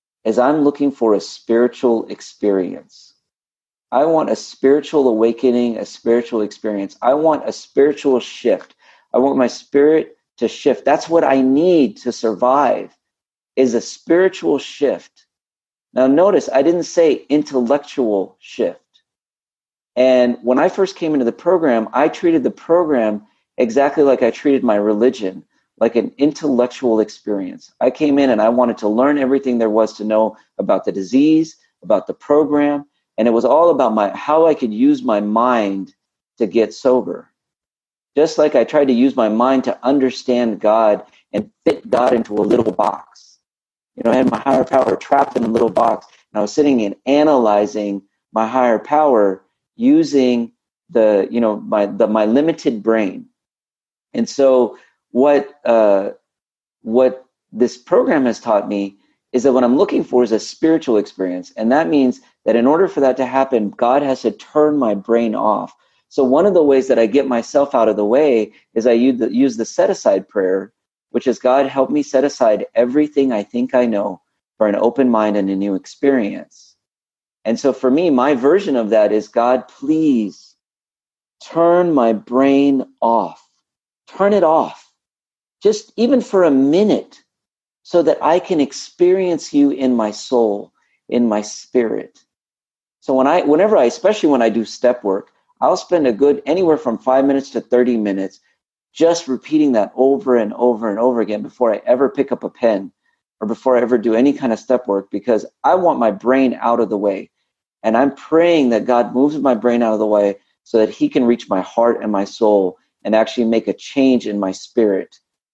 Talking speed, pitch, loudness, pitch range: 180 wpm, 125 Hz, -16 LUFS, 110-140 Hz